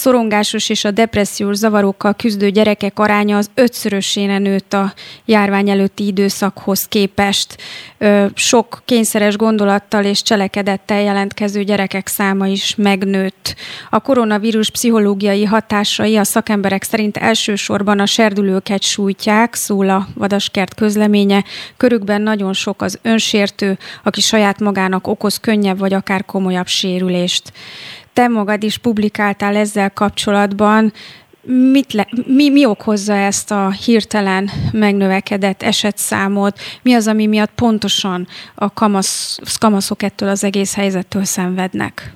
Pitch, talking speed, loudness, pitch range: 205 Hz, 120 wpm, -14 LUFS, 195-215 Hz